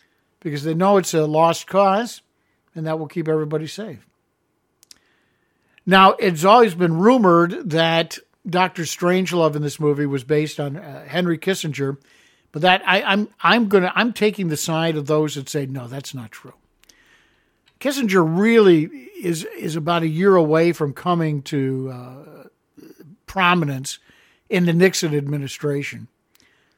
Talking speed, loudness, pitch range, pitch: 145 wpm, -19 LUFS, 150-185 Hz, 165 Hz